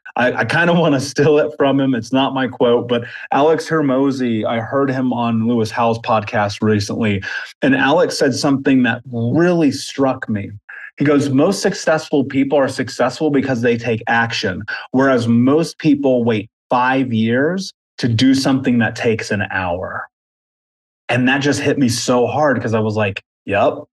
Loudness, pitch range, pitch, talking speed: -16 LUFS, 115-140 Hz, 130 Hz, 175 wpm